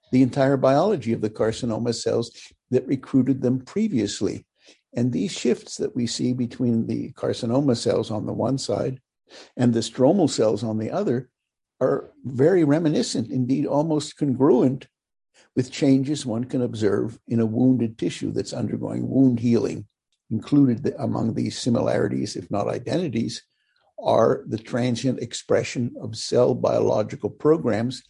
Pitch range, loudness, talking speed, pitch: 115-135 Hz, -23 LUFS, 140 wpm, 125 Hz